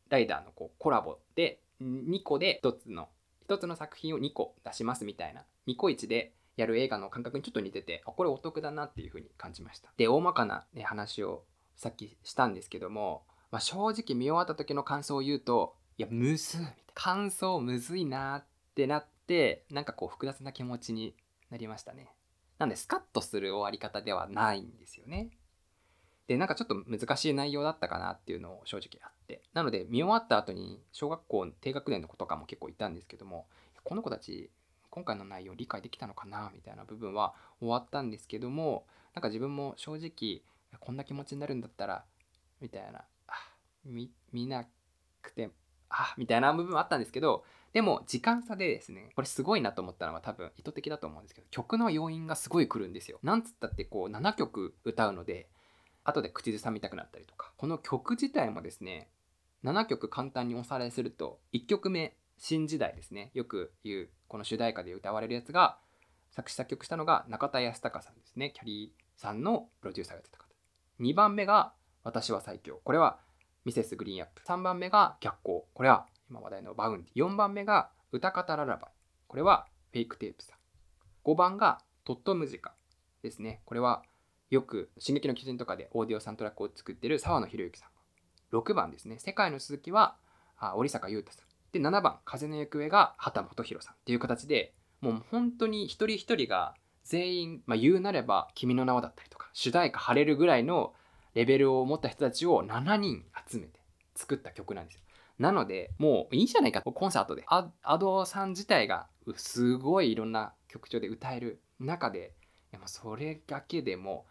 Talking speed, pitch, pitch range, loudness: 375 characters per minute, 140 Hz, 115-175 Hz, -32 LUFS